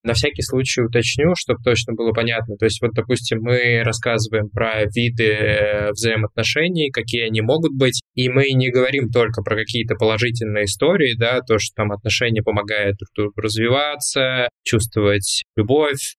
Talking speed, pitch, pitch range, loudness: 145 wpm, 115 Hz, 110-125 Hz, -18 LUFS